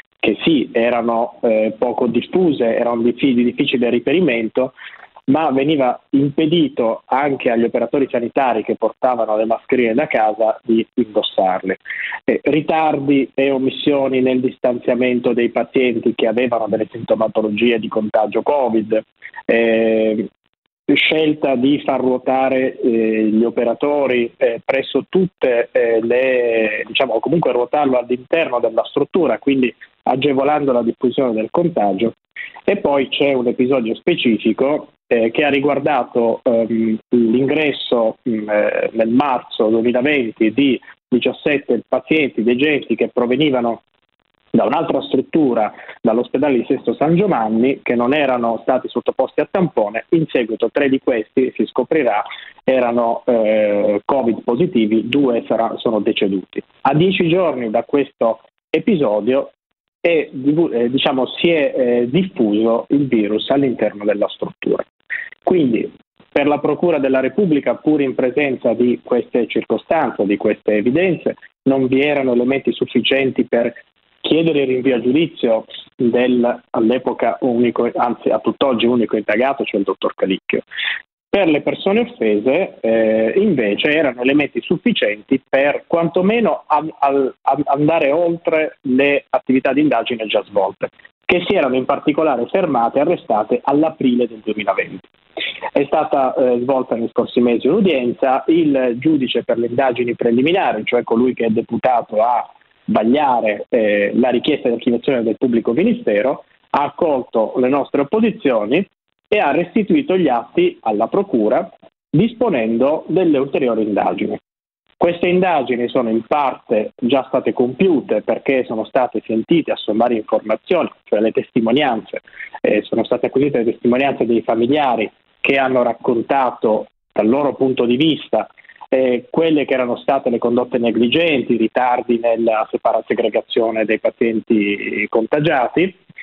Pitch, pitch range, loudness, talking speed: 125 Hz, 115-140 Hz, -17 LUFS, 130 wpm